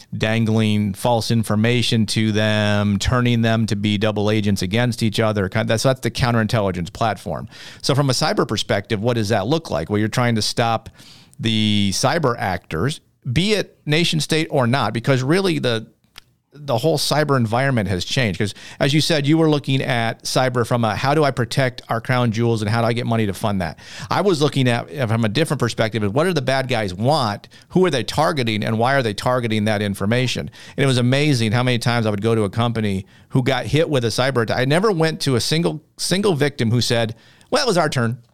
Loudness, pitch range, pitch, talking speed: -19 LUFS, 110-135 Hz, 120 Hz, 220 wpm